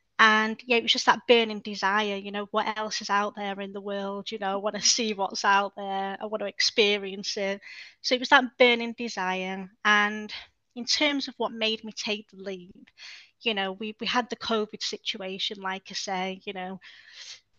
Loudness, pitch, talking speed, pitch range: -26 LUFS, 210 Hz, 210 wpm, 195-230 Hz